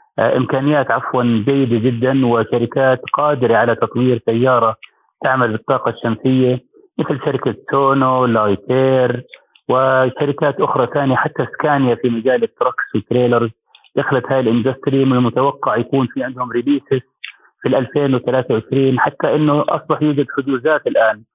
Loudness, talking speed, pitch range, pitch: -16 LUFS, 120 wpm, 120-135 Hz, 130 Hz